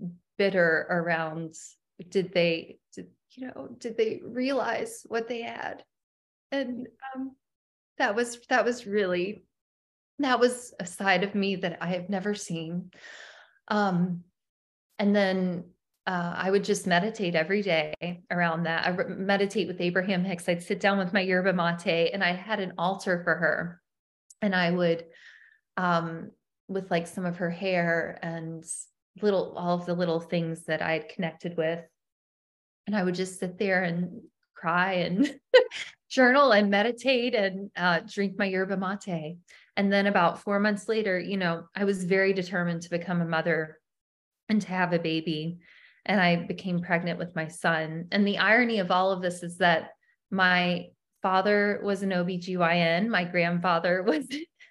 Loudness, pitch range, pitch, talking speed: -27 LUFS, 170-205 Hz, 185 Hz, 160 wpm